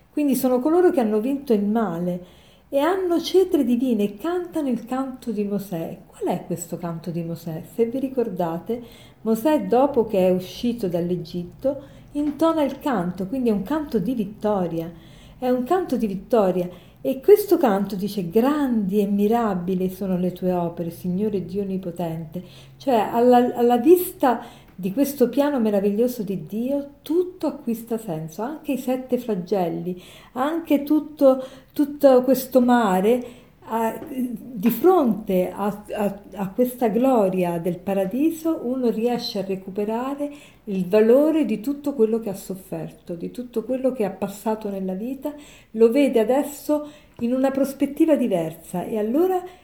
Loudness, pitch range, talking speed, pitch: -22 LUFS, 195-270 Hz, 145 wpm, 230 Hz